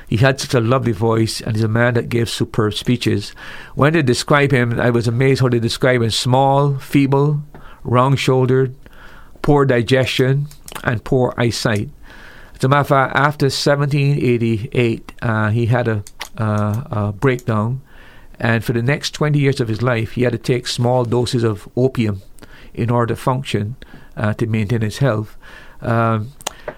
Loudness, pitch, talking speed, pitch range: -17 LUFS, 125 Hz, 165 wpm, 115-135 Hz